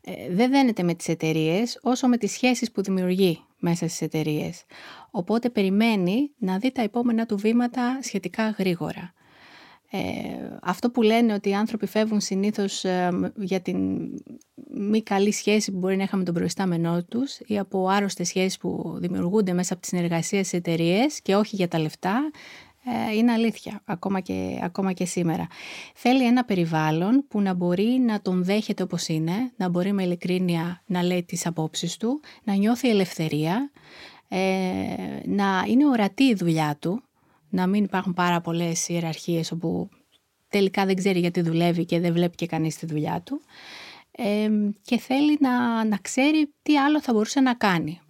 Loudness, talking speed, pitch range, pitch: -24 LUFS, 165 wpm, 175-230 Hz, 195 Hz